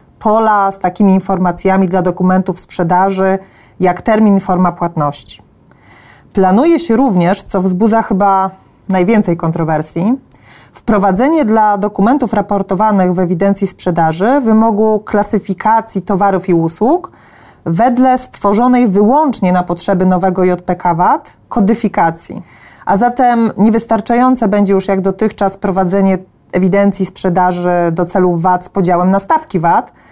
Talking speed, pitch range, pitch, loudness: 115 wpm, 185-220 Hz, 195 Hz, -12 LUFS